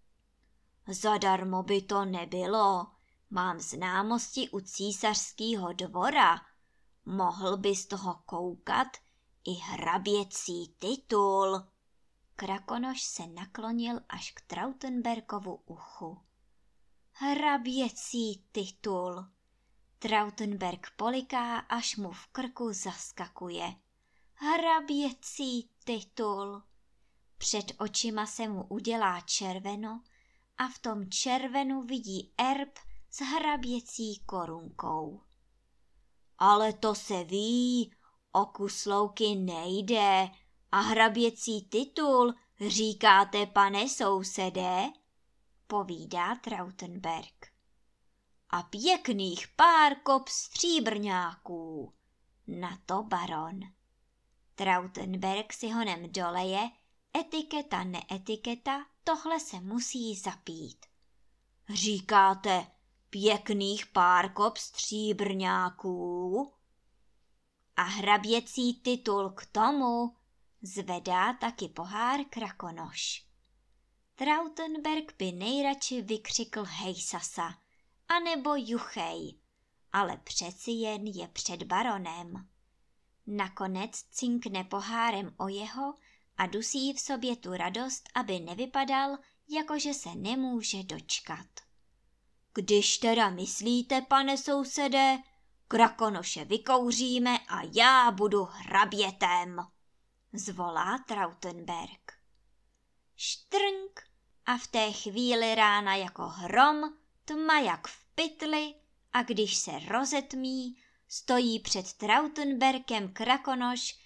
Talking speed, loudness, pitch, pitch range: 85 wpm, -30 LUFS, 215 Hz, 190-250 Hz